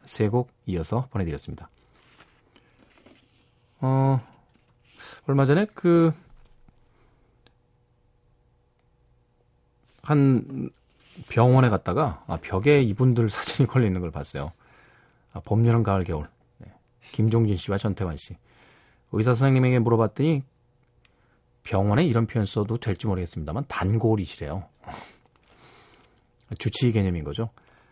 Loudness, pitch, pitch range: -24 LUFS, 120 Hz, 100-125 Hz